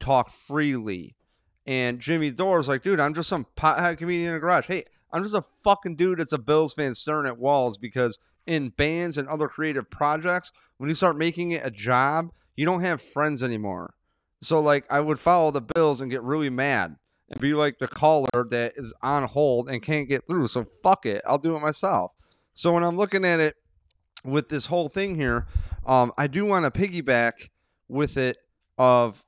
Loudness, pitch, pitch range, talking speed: -24 LUFS, 145 Hz, 125-165 Hz, 200 wpm